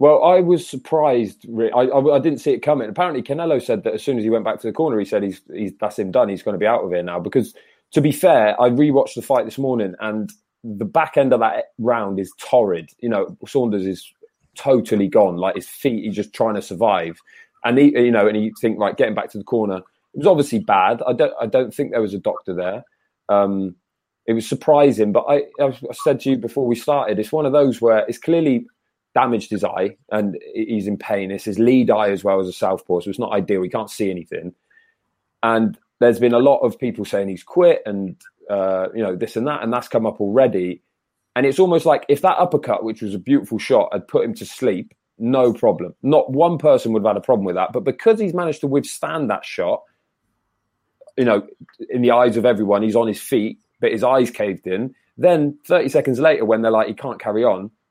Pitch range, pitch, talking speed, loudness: 105-140 Hz, 115 Hz, 240 wpm, -19 LUFS